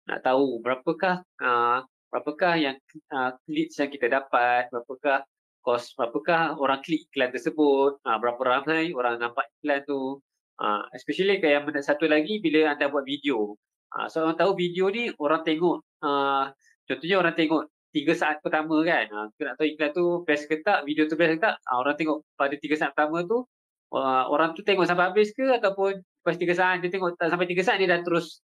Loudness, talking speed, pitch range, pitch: -25 LUFS, 205 wpm, 135-170 Hz, 150 Hz